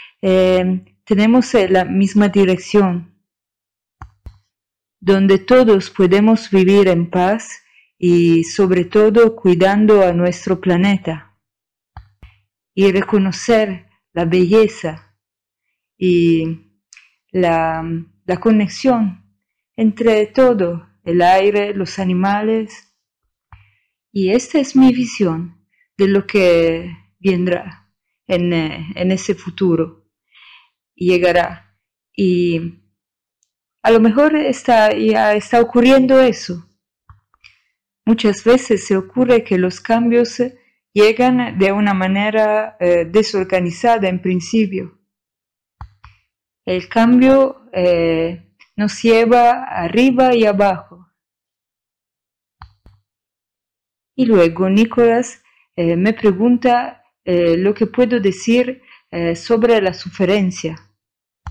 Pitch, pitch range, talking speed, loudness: 185 Hz, 165-220 Hz, 90 wpm, -15 LUFS